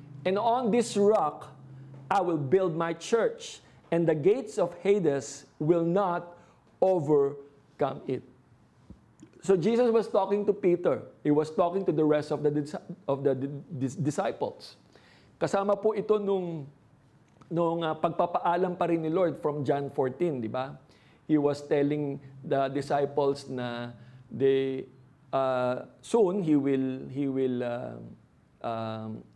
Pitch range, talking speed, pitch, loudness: 135-180 Hz, 135 wpm, 150 Hz, -28 LUFS